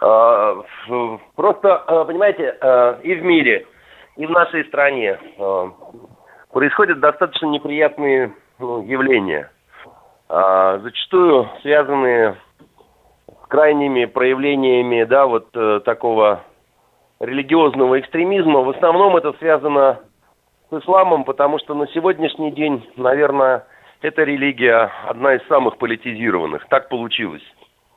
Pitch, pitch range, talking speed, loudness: 140 Hz, 125-155 Hz, 90 wpm, -16 LUFS